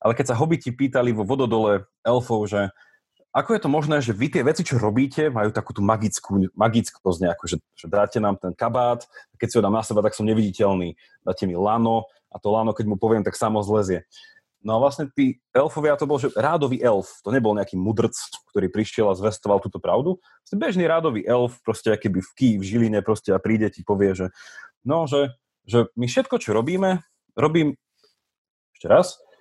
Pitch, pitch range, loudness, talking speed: 115 Hz, 105-140 Hz, -22 LUFS, 205 wpm